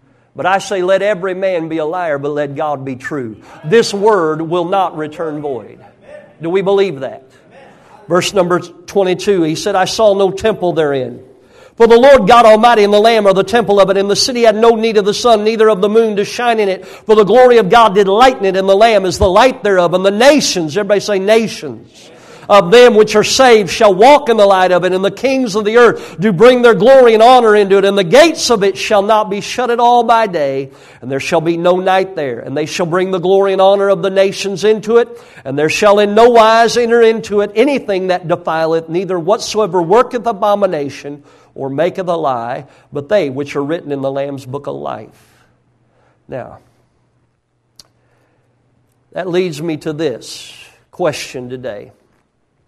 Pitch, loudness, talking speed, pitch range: 195 Hz, -11 LUFS, 210 wpm, 165-220 Hz